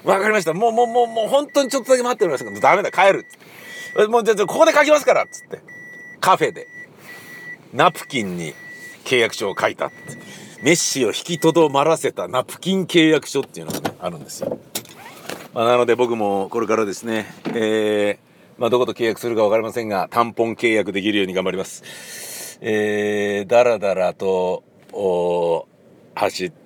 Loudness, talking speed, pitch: -19 LUFS, 355 characters per minute, 120 Hz